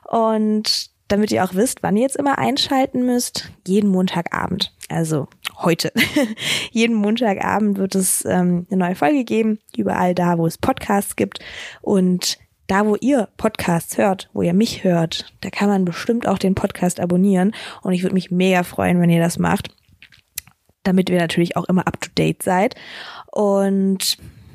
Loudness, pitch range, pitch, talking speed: -19 LUFS, 180-215 Hz, 195 Hz, 165 wpm